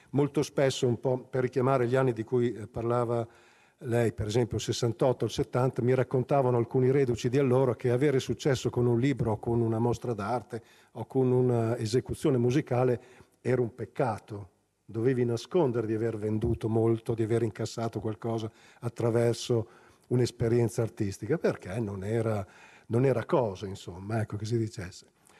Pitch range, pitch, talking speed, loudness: 115-125 Hz, 120 Hz, 160 wpm, -29 LUFS